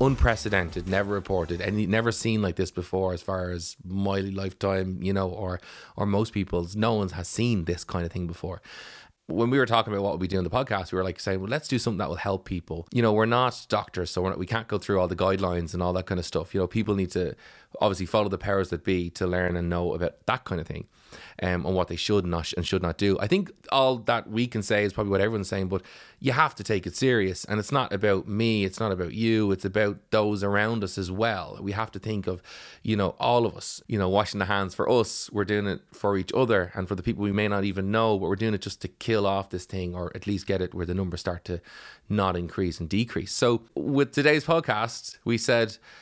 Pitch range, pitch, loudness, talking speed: 90-110 Hz, 100 Hz, -27 LUFS, 260 wpm